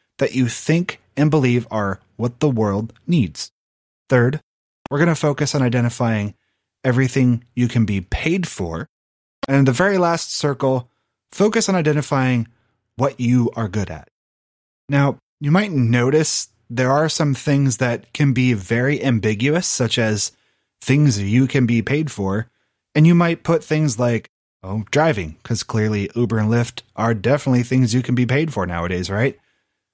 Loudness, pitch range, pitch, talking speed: -19 LUFS, 110-145 Hz, 125 Hz, 160 wpm